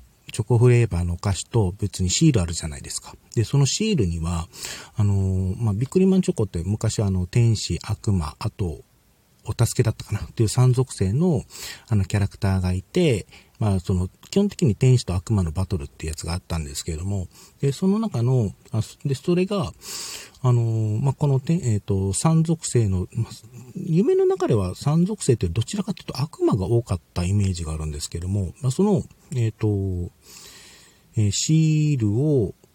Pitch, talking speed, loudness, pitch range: 110 Hz, 365 characters per minute, -23 LUFS, 95-135 Hz